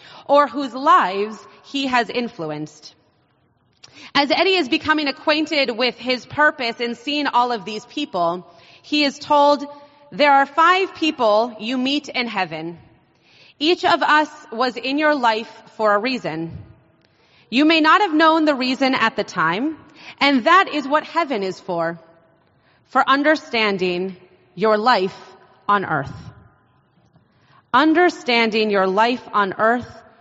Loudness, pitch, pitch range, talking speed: -18 LUFS, 240 Hz, 185-290 Hz, 135 wpm